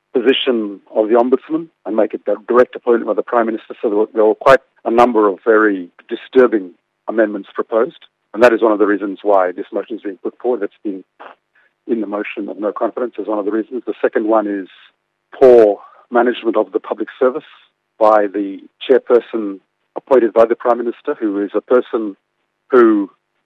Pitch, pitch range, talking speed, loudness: 110 Hz, 100-120 Hz, 190 wpm, -15 LUFS